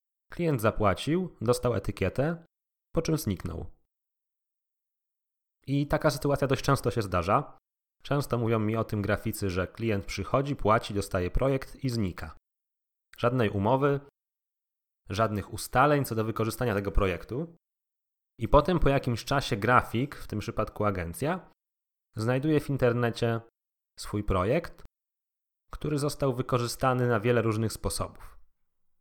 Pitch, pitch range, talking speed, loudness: 115 Hz, 100-135 Hz, 120 wpm, -29 LUFS